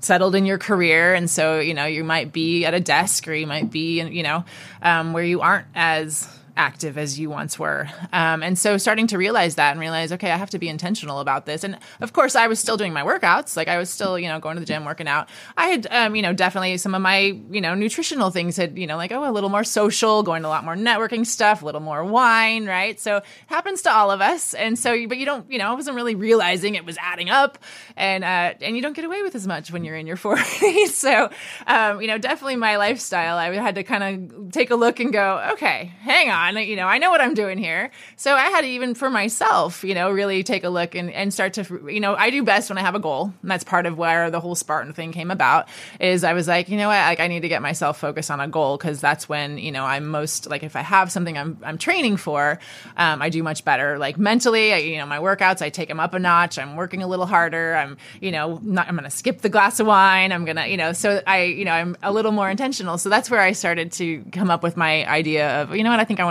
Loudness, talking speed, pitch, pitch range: -20 LUFS, 275 wpm, 185 Hz, 165-215 Hz